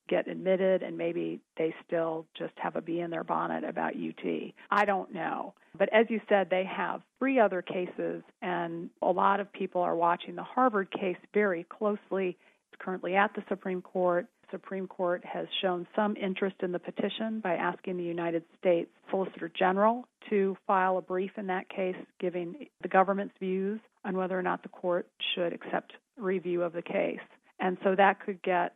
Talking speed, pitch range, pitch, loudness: 190 wpm, 175-200 Hz, 185 Hz, -31 LUFS